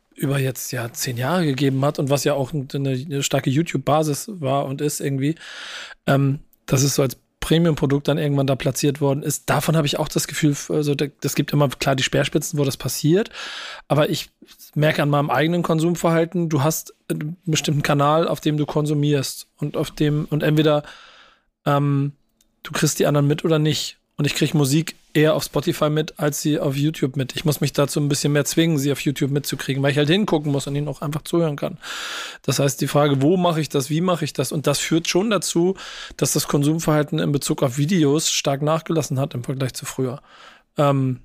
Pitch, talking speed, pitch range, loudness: 150 Hz, 210 wpm, 140-155 Hz, -21 LUFS